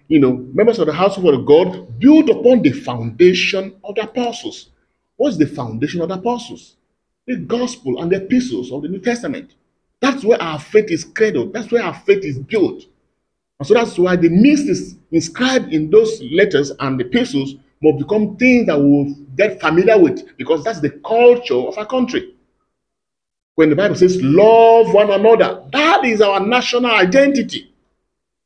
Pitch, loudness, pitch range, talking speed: 220 Hz, -15 LUFS, 165-250 Hz, 175 wpm